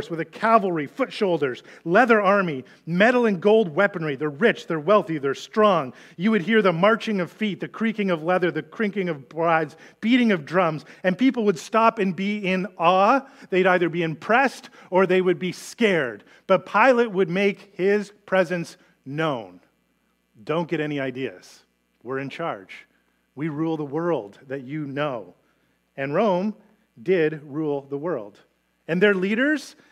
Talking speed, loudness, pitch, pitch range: 165 wpm, -22 LUFS, 185 Hz, 160-210 Hz